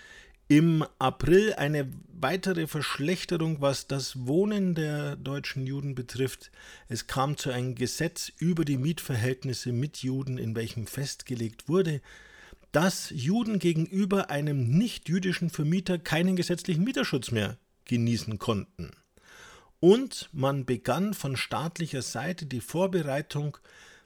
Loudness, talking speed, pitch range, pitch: -29 LUFS, 115 wpm, 130-180 Hz, 145 Hz